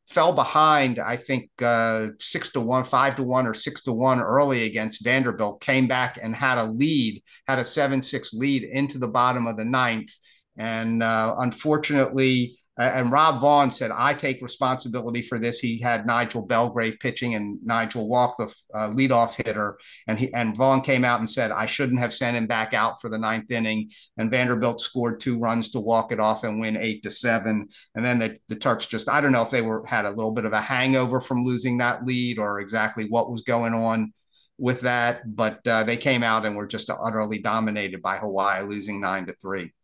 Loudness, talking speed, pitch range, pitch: -23 LUFS, 210 wpm, 110-125 Hz, 120 Hz